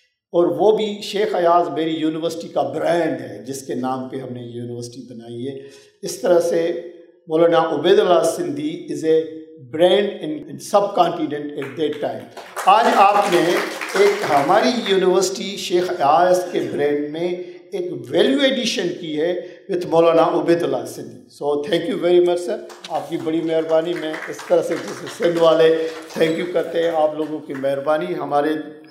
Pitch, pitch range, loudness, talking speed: 170 Hz, 155-185 Hz, -19 LUFS, 170 wpm